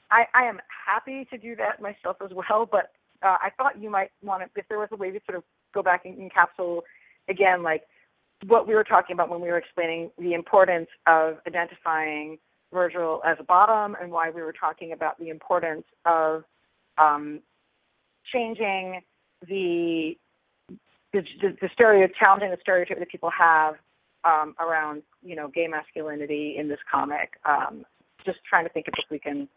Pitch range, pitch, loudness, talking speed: 160-195 Hz, 175 Hz, -24 LUFS, 180 wpm